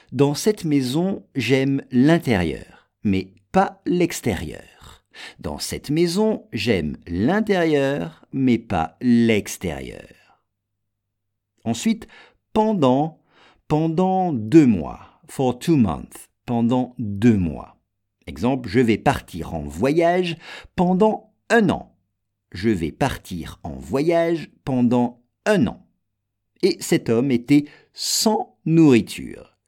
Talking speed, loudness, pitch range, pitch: 100 wpm, -21 LUFS, 100-165 Hz, 125 Hz